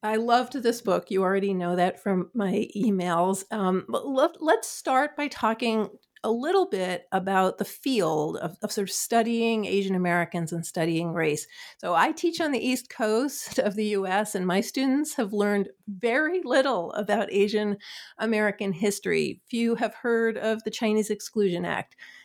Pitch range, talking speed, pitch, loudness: 190-235 Hz, 165 wpm, 210 Hz, -26 LUFS